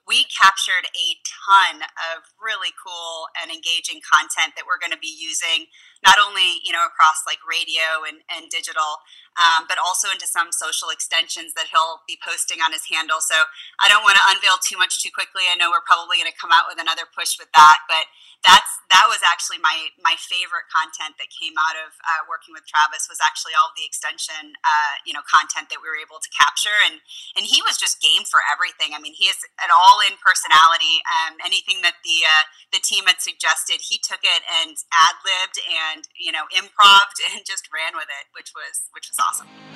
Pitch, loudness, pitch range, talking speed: 165 Hz, -17 LUFS, 160-185 Hz, 210 wpm